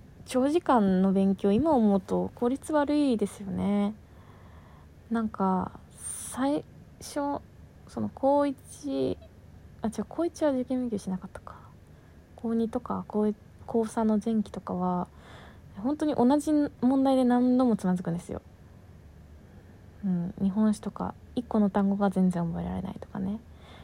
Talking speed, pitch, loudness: 235 characters per minute, 205 Hz, -28 LUFS